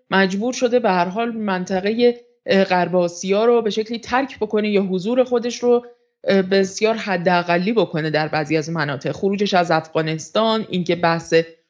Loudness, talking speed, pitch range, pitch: -19 LUFS, 150 wpm, 175-230 Hz, 195 Hz